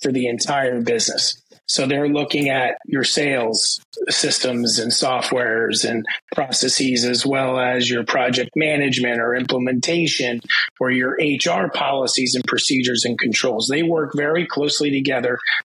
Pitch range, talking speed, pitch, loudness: 125-145 Hz, 140 wpm, 130 Hz, -18 LUFS